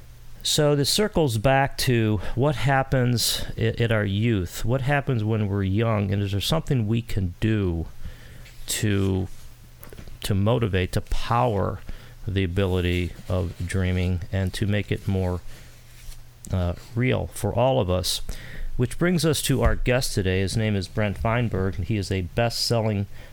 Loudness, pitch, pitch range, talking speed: -24 LUFS, 110 Hz, 95-120 Hz, 155 wpm